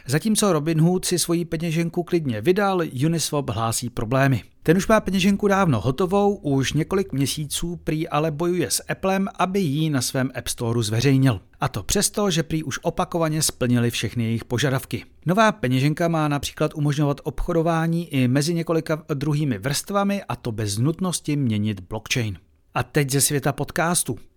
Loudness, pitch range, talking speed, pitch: -22 LUFS, 125-175 Hz, 160 wpm, 150 Hz